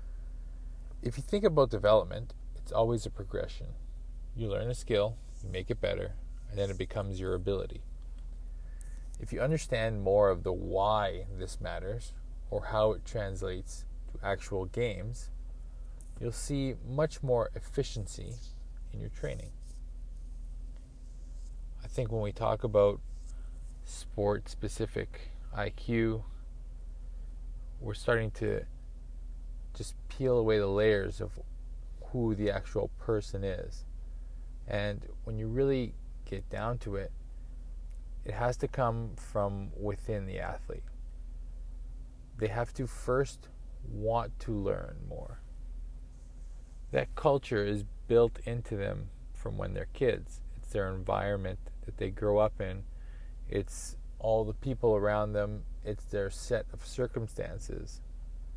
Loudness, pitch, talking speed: -34 LUFS, 95 Hz, 125 wpm